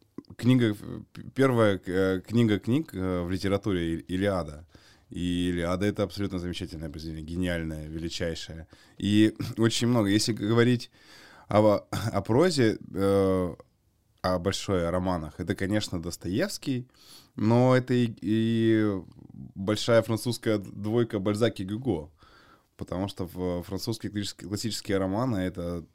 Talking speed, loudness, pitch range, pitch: 105 wpm, -27 LUFS, 90-115 Hz, 100 Hz